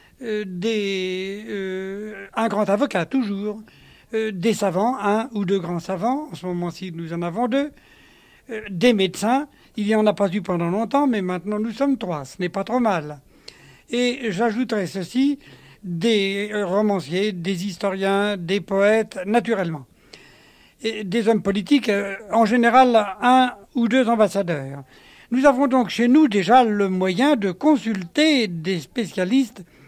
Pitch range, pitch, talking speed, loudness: 190-235 Hz, 210 Hz, 150 wpm, -21 LUFS